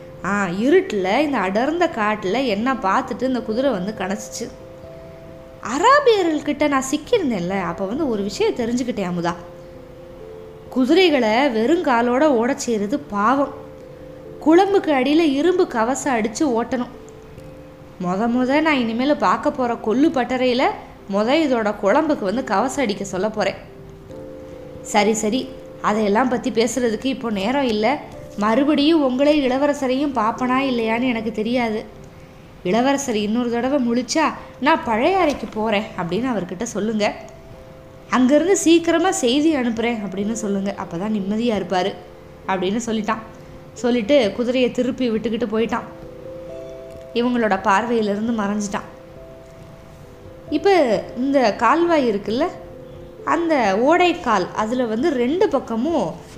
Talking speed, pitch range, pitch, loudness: 110 wpm, 210-280 Hz, 240 Hz, -19 LUFS